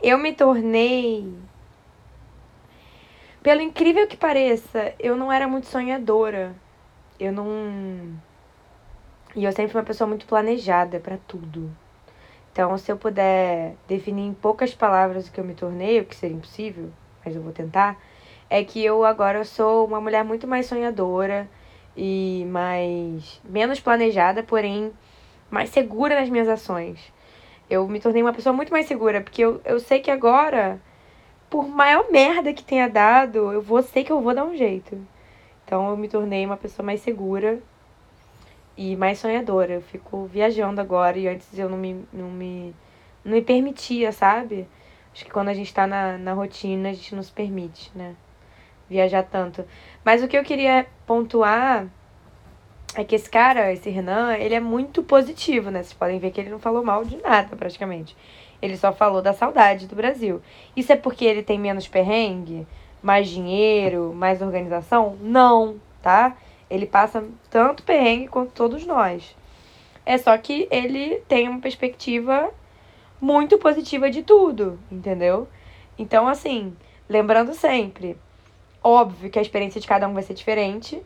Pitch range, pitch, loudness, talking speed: 190-240 Hz, 210 Hz, -21 LUFS, 160 wpm